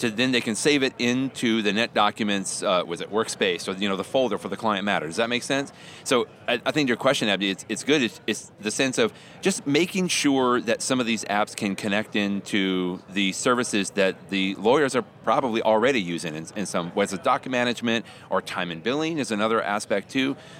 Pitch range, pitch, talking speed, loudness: 100-130 Hz, 110 Hz, 225 wpm, -24 LUFS